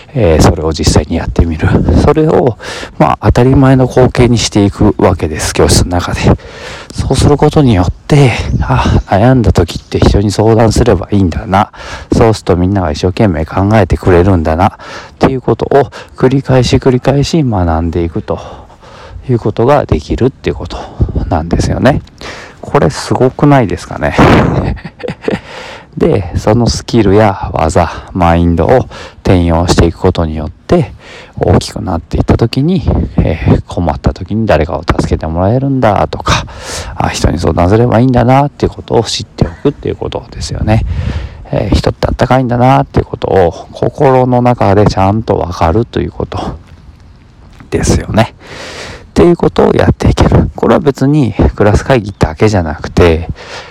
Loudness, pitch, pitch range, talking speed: -10 LUFS, 100 Hz, 85-120 Hz, 335 characters per minute